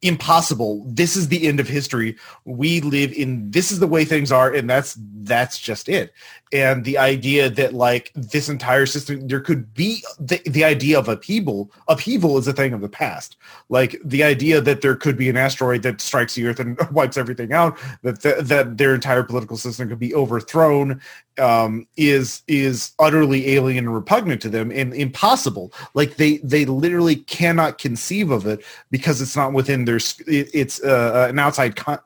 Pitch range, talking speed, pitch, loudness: 125-155 Hz, 185 wpm, 135 Hz, -19 LUFS